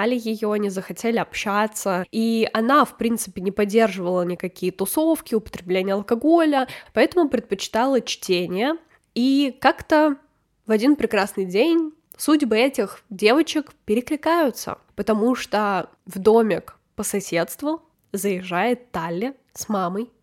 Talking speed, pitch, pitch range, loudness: 110 wpm, 225 Hz, 195-270 Hz, -22 LUFS